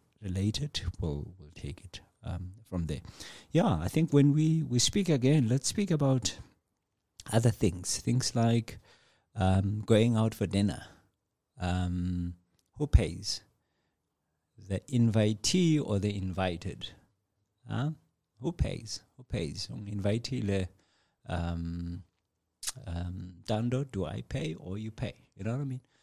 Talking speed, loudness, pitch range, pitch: 130 wpm, -31 LUFS, 90-125 Hz, 105 Hz